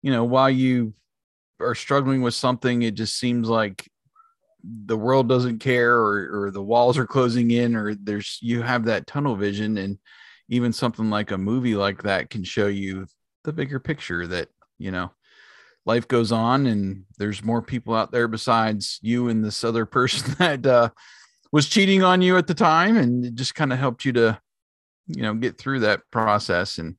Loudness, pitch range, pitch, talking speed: -22 LUFS, 105-130 Hz, 120 Hz, 190 wpm